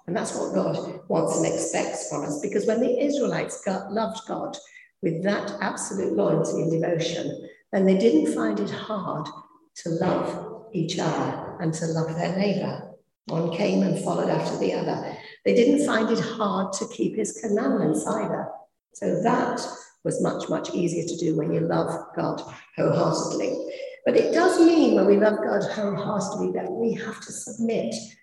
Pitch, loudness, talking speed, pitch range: 210 Hz, -25 LUFS, 170 wpm, 170-230 Hz